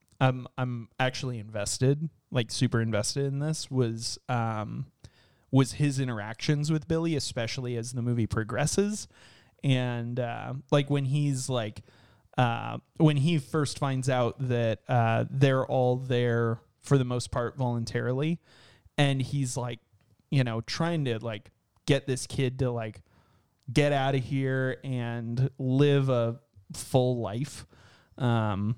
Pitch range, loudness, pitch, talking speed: 115-140 Hz, -29 LUFS, 125 Hz, 140 wpm